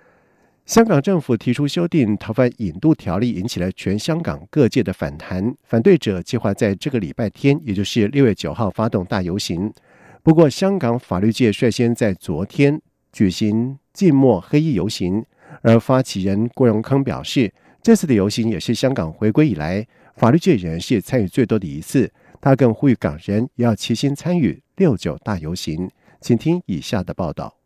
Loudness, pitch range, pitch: -19 LUFS, 105-145 Hz, 120 Hz